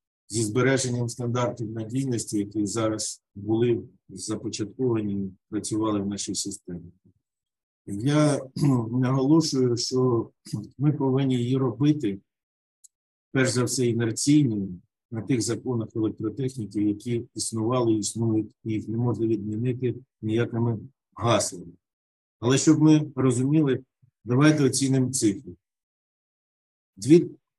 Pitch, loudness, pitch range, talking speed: 120 Hz, -25 LUFS, 110-130 Hz, 100 wpm